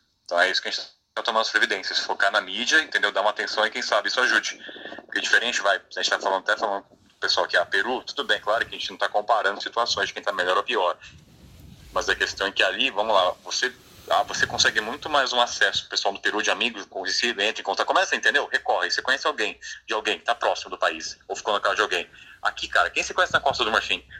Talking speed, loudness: 270 wpm, -23 LUFS